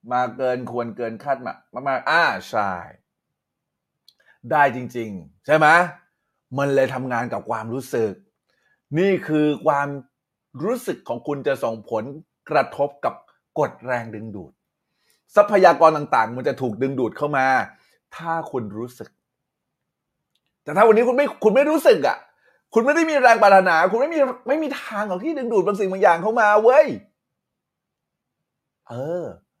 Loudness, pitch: -20 LUFS, 150 Hz